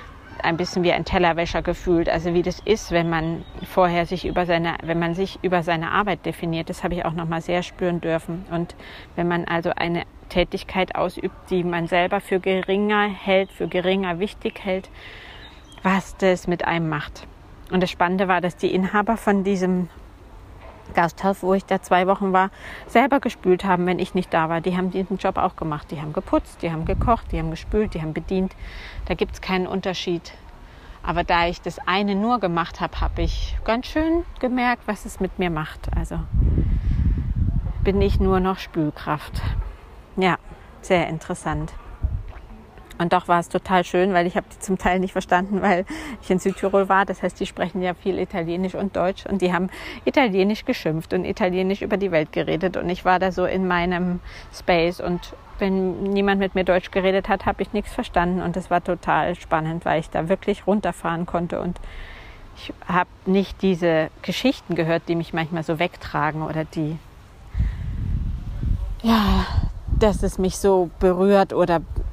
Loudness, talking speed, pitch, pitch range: -23 LUFS, 180 wpm, 180 Hz, 165-190 Hz